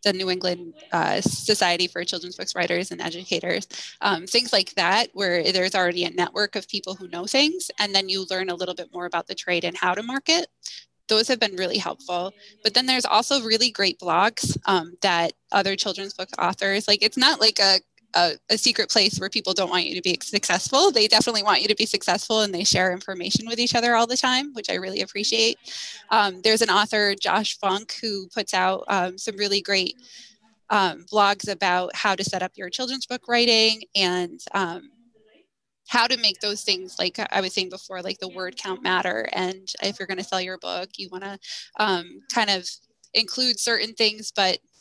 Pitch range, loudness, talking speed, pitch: 185-220 Hz, -22 LUFS, 210 wpm, 200 Hz